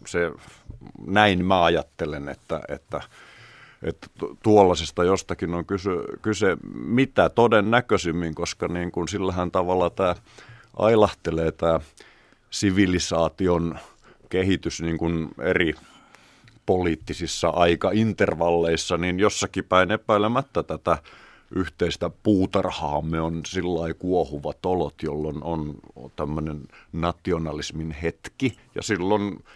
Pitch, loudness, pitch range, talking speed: 85 Hz, -24 LUFS, 80-95 Hz, 95 wpm